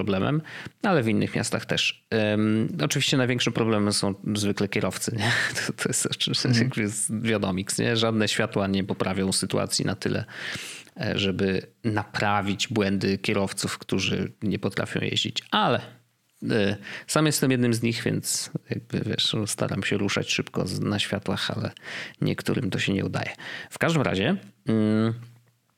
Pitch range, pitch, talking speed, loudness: 100-120 Hz, 110 Hz, 135 wpm, -25 LUFS